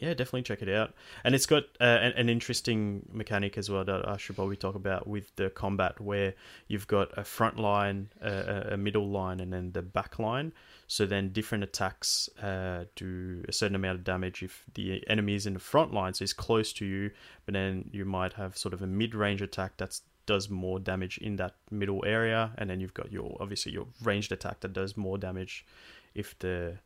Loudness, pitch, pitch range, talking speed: -32 LUFS, 100 Hz, 95-105 Hz, 215 wpm